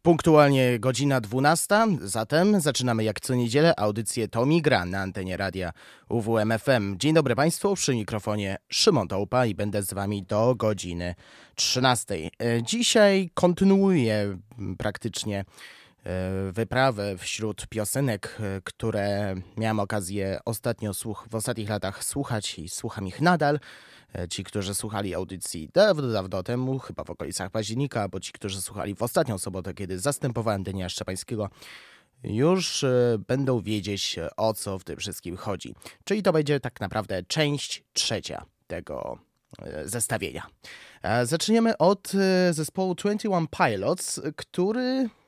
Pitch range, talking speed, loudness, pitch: 100-145 Hz, 125 wpm, -26 LUFS, 115 Hz